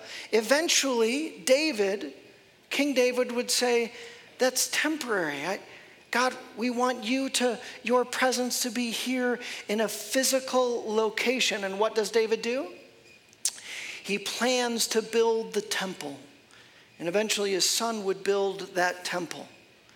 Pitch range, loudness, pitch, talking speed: 210-250 Hz, -27 LUFS, 235 Hz, 125 wpm